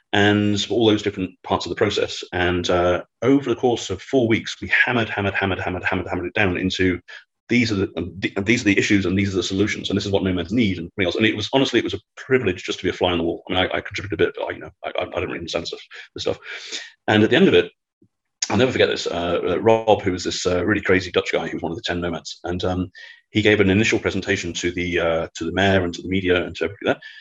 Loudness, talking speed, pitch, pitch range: -21 LUFS, 290 wpm, 95 Hz, 90-105 Hz